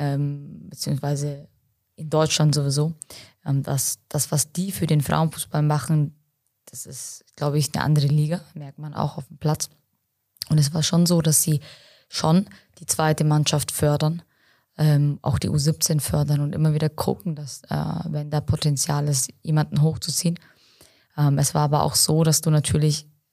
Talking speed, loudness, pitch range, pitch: 155 wpm, -22 LUFS, 145-155 Hz, 150 Hz